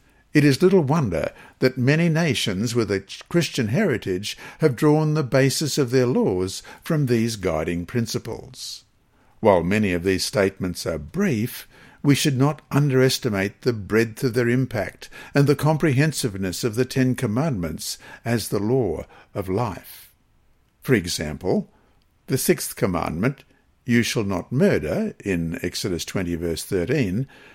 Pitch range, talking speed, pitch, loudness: 100-145 Hz, 140 wpm, 125 Hz, -22 LUFS